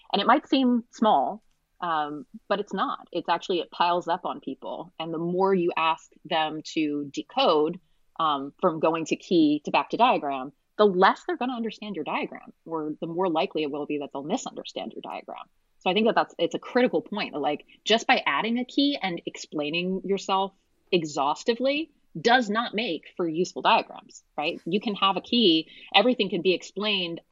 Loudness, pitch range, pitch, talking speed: -26 LUFS, 160-235 Hz, 190 Hz, 195 wpm